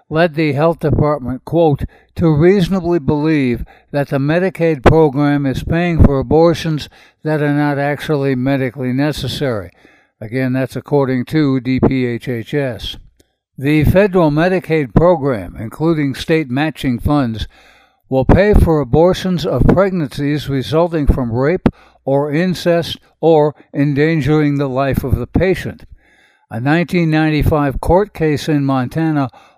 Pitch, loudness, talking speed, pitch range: 145 Hz, -15 LUFS, 120 wpm, 130-160 Hz